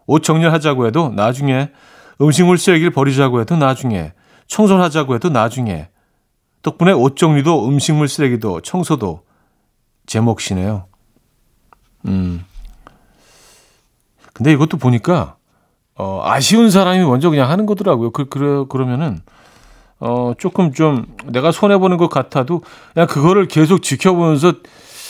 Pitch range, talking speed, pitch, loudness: 125-175 Hz, 285 characters per minute, 145 Hz, -14 LUFS